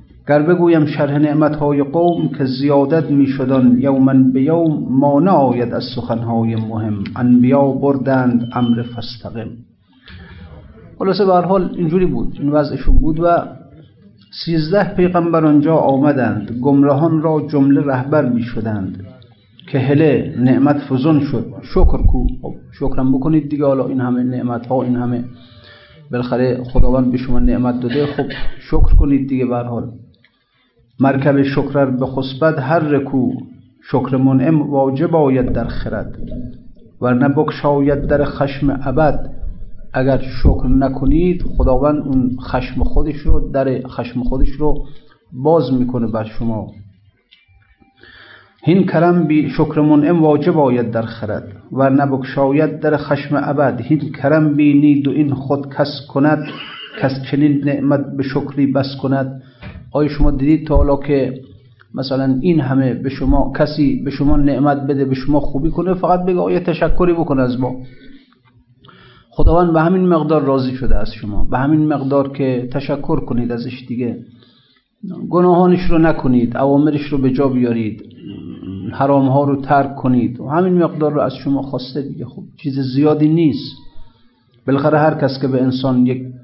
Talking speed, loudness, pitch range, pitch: 145 wpm, -16 LUFS, 125-150 Hz, 135 Hz